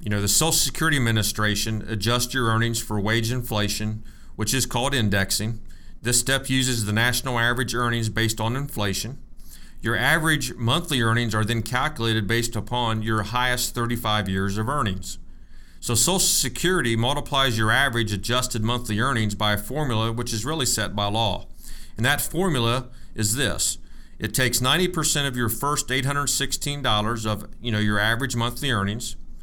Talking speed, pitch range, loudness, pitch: 160 wpm, 110-130 Hz, -23 LUFS, 115 Hz